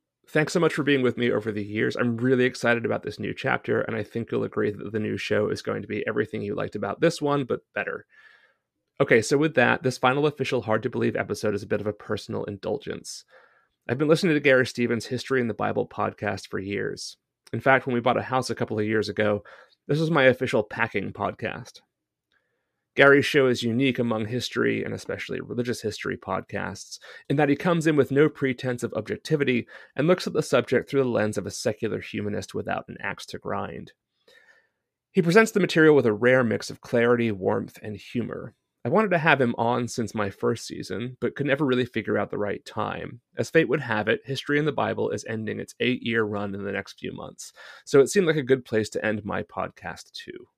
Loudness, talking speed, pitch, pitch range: -25 LUFS, 225 wpm, 125 Hz, 110-140 Hz